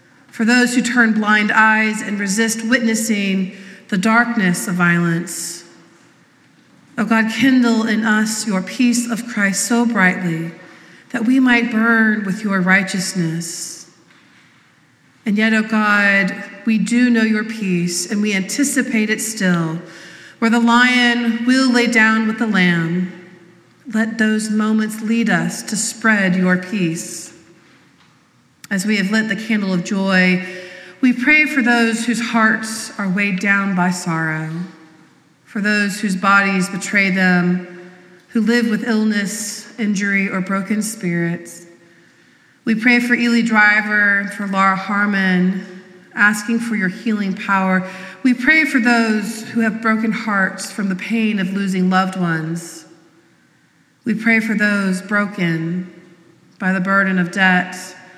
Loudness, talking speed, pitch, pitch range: -16 LUFS, 140 wpm, 205 Hz, 185-225 Hz